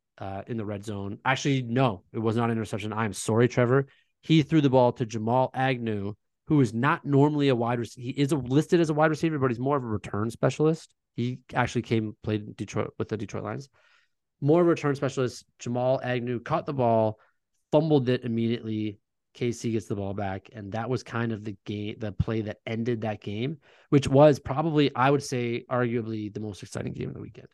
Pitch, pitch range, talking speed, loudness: 120 Hz, 110-135 Hz, 215 wpm, -27 LUFS